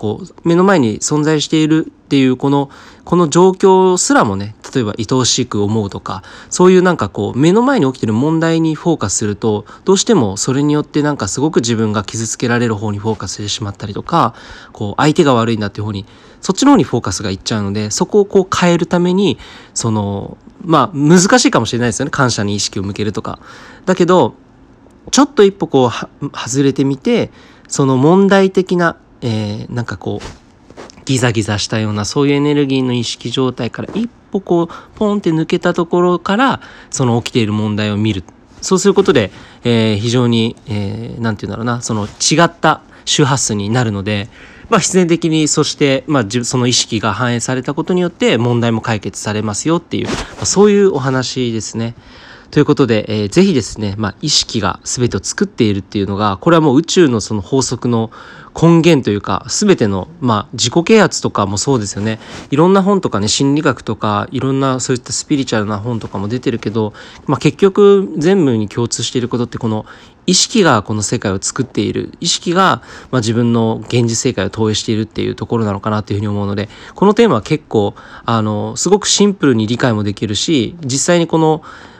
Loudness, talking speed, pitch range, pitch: -14 LUFS, 410 characters per minute, 110-160 Hz, 125 Hz